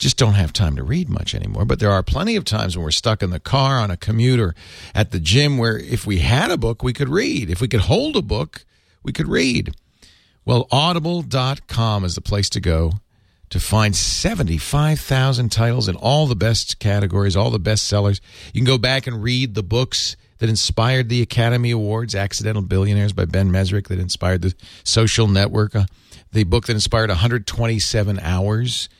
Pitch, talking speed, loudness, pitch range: 110 Hz, 195 wpm, -19 LUFS, 95-120 Hz